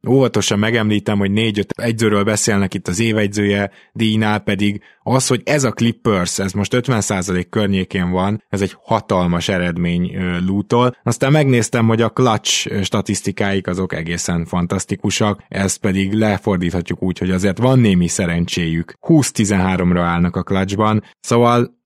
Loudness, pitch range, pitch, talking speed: -17 LUFS, 95-115 Hz, 100 Hz, 135 wpm